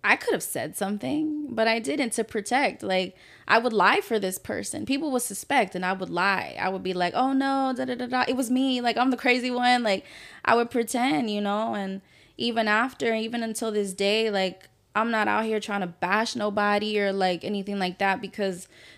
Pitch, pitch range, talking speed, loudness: 220 Hz, 195-245 Hz, 220 wpm, -25 LUFS